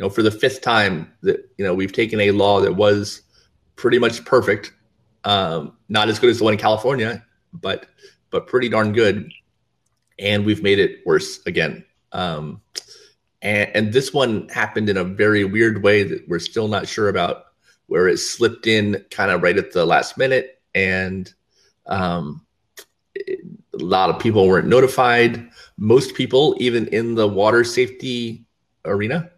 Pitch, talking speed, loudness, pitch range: 110 Hz, 170 wpm, -18 LUFS, 105-130 Hz